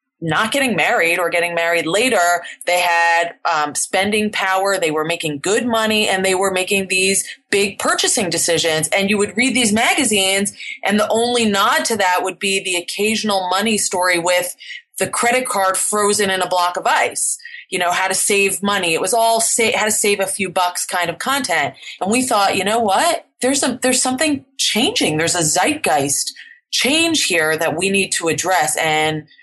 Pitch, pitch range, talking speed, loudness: 195 Hz, 175-230 Hz, 190 wpm, -16 LUFS